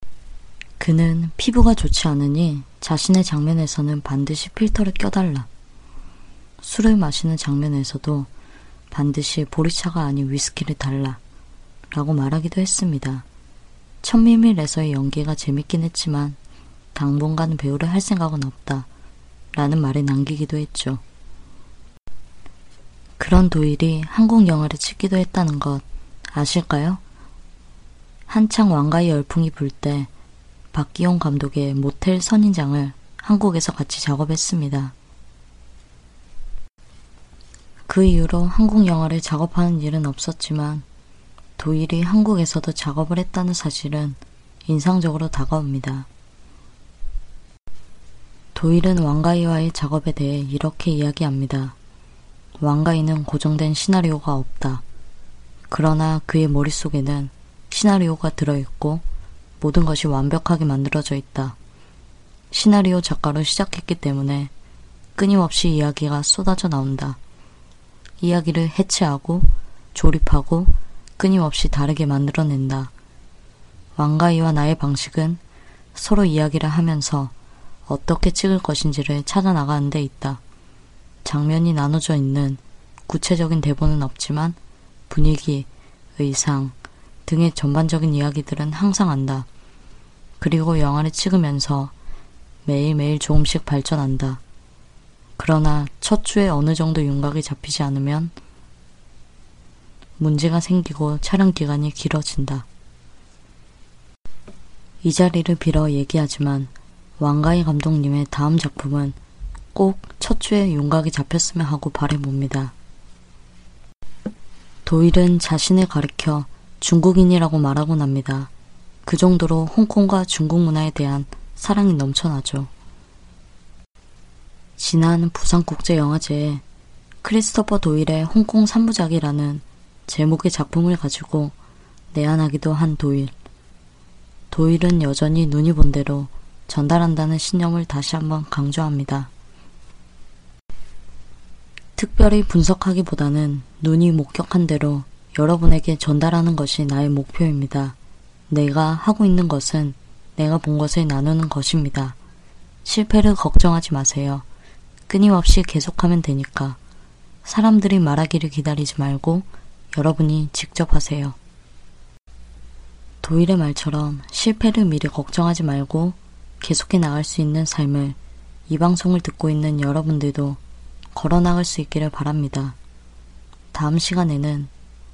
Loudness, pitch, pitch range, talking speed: -19 LUFS, 150 Hz, 135-165 Hz, 260 characters per minute